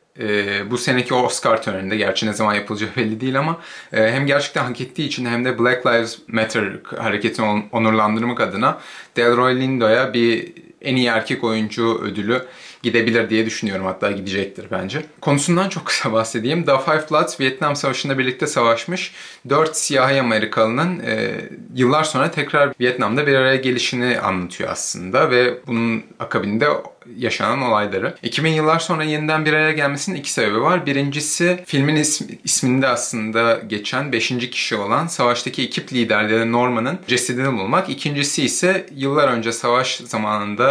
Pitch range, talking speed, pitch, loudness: 115-145 Hz, 150 wpm, 125 Hz, -19 LUFS